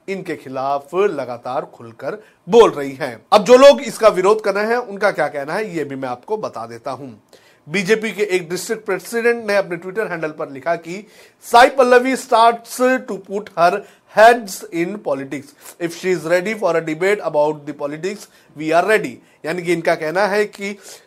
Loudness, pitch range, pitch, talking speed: -17 LUFS, 155-220 Hz, 195 Hz, 145 wpm